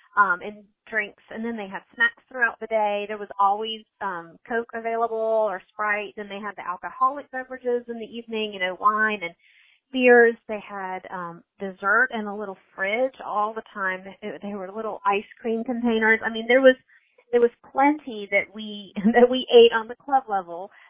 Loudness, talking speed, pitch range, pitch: -23 LUFS, 190 wpm, 200-235 Hz, 215 Hz